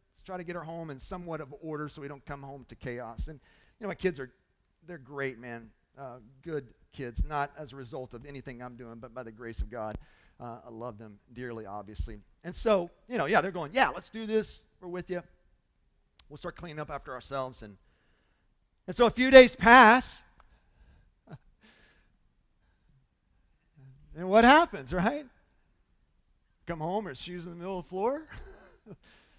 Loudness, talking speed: -26 LUFS, 180 wpm